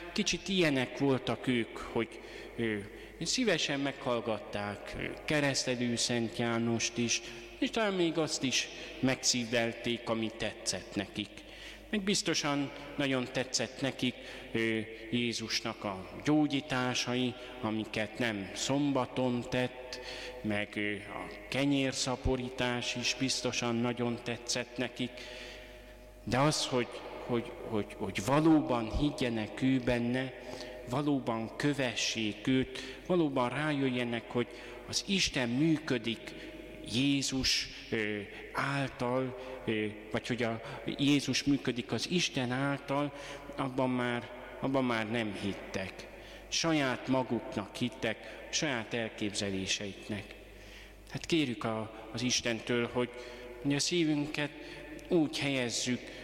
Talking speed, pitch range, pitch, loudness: 100 wpm, 115-135 Hz, 125 Hz, -33 LUFS